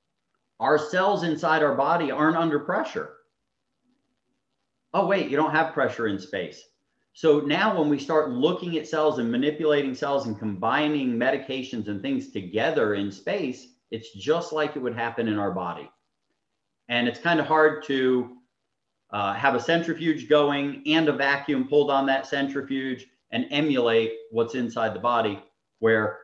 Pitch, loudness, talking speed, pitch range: 145 Hz, -25 LUFS, 160 wpm, 125-160 Hz